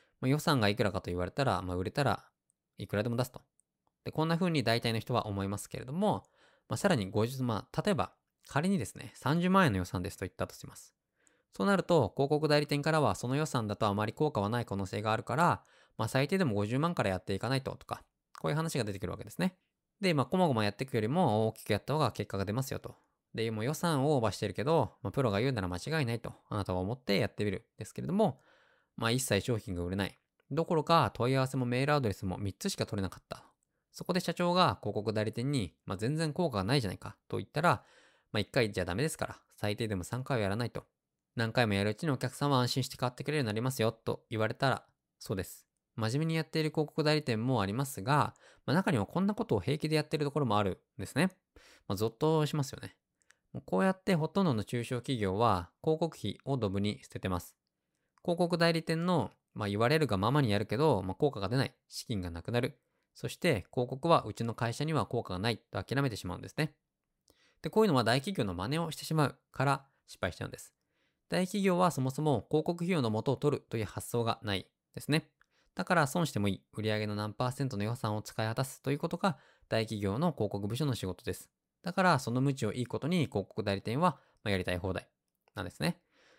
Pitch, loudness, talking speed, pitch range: 125 Hz, -33 LUFS, 445 characters per minute, 105-150 Hz